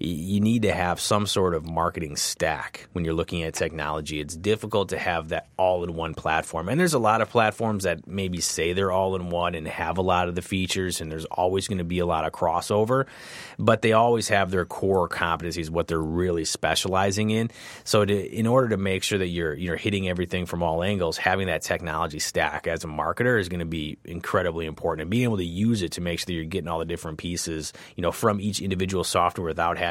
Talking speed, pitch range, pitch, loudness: 225 wpm, 85-105 Hz, 90 Hz, -25 LUFS